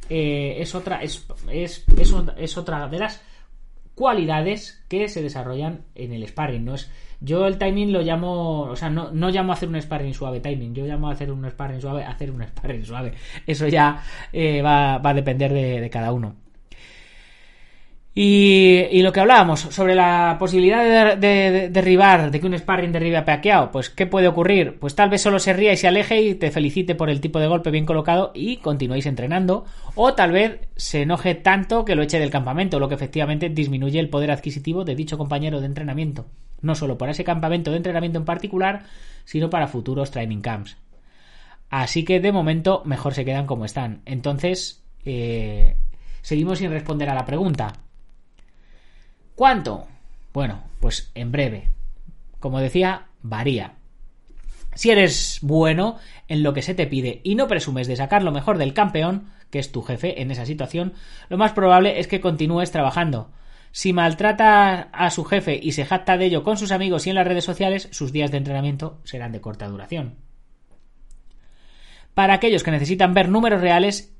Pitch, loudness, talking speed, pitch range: 160 Hz, -20 LUFS, 190 wpm, 140-185 Hz